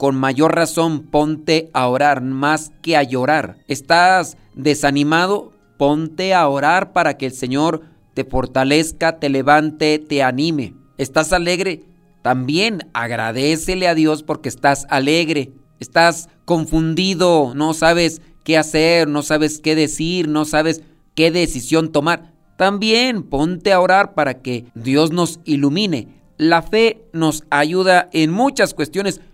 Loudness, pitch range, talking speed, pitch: -16 LUFS, 145-170 Hz, 135 wpm, 155 Hz